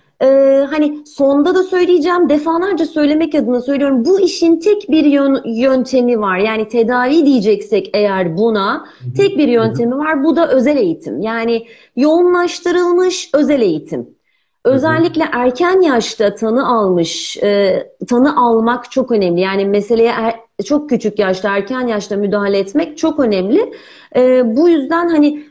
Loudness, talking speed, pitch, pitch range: -13 LUFS, 135 wpm, 265 Hz, 225-320 Hz